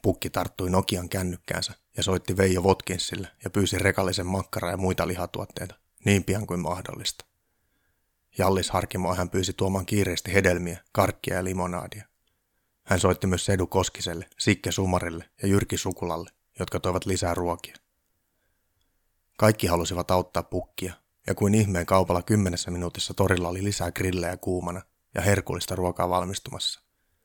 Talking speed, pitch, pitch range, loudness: 135 wpm, 95 Hz, 90-95 Hz, -26 LUFS